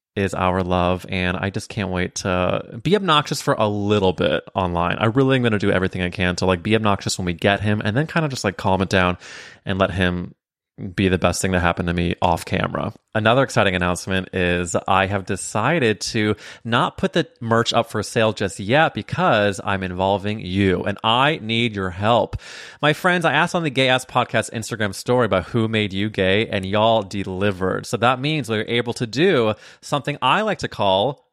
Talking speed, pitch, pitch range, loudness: 215 wpm, 105 Hz, 95-120 Hz, -20 LUFS